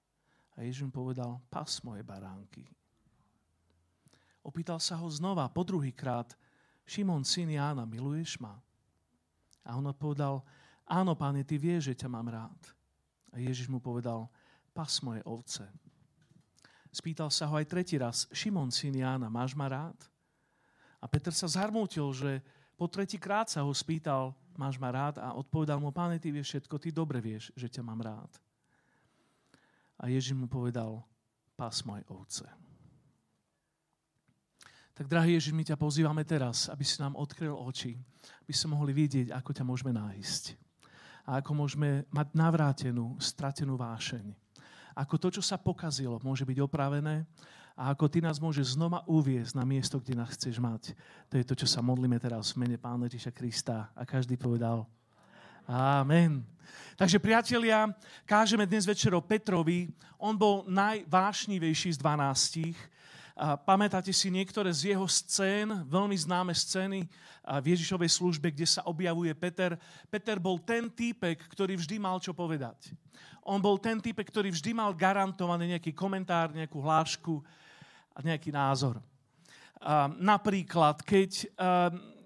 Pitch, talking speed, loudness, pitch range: 150 Hz, 145 wpm, -32 LUFS, 130-175 Hz